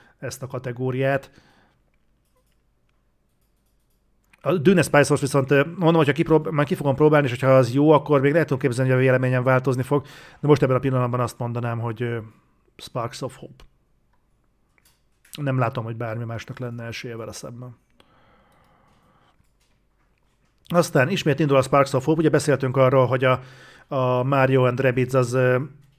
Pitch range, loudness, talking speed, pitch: 125-145 Hz, -21 LUFS, 145 wpm, 130 Hz